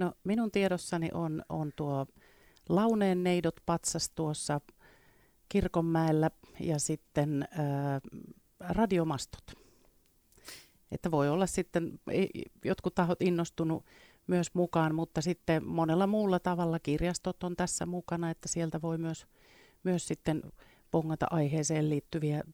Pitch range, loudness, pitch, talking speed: 155-180 Hz, -32 LUFS, 165 Hz, 110 wpm